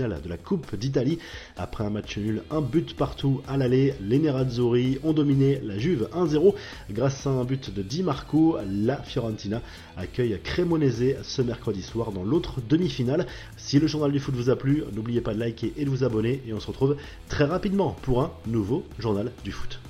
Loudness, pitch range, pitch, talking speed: -26 LUFS, 110-145 Hz, 130 Hz, 195 wpm